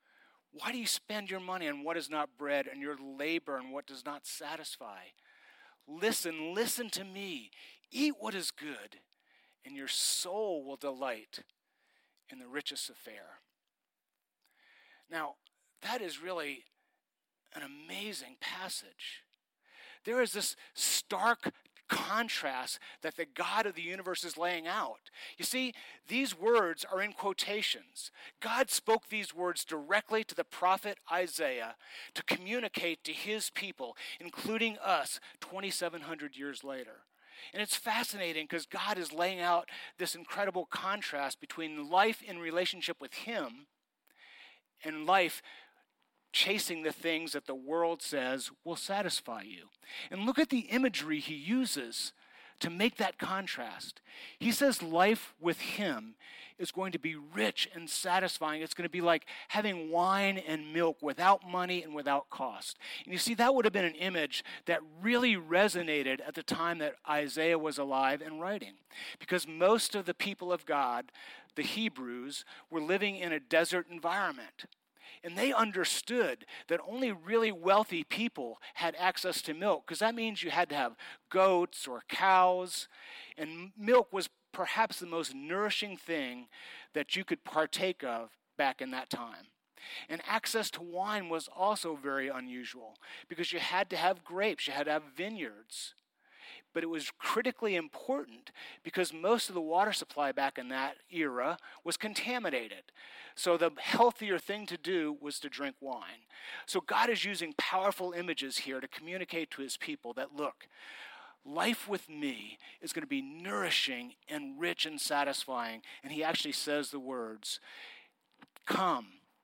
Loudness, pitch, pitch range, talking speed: -34 LUFS, 180 Hz, 160-225 Hz, 150 wpm